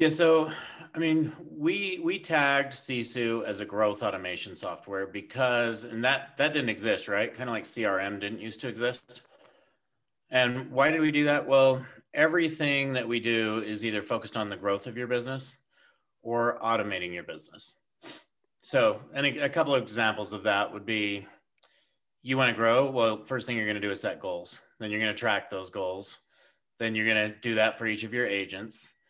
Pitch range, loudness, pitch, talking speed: 110-135 Hz, -28 LUFS, 120 Hz, 195 wpm